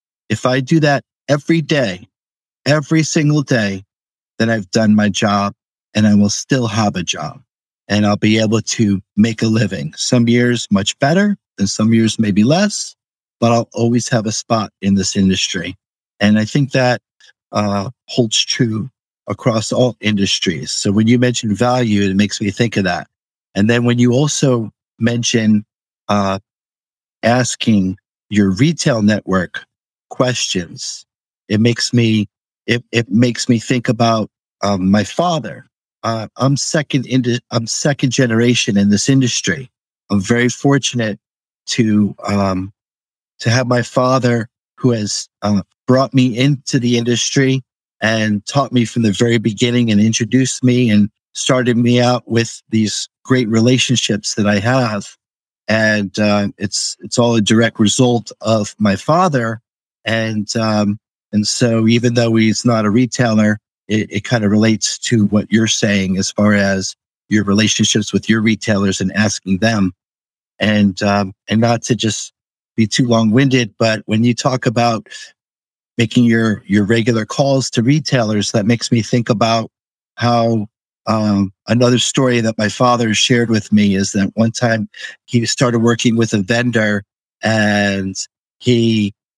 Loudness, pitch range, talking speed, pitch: -15 LUFS, 105-125 Hz, 155 wpm, 115 Hz